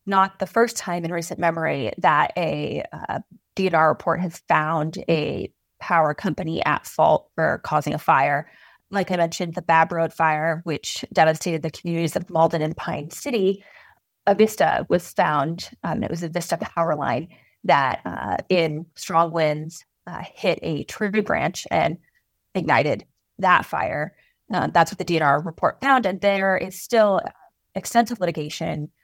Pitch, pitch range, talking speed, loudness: 170 Hz, 160-190 Hz, 160 wpm, -22 LUFS